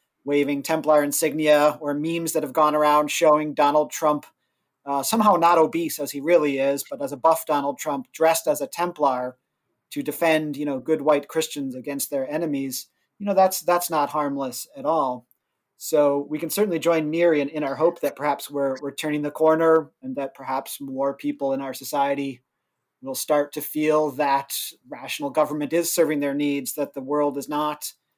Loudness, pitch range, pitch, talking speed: -23 LUFS, 140-160 Hz, 150 Hz, 185 wpm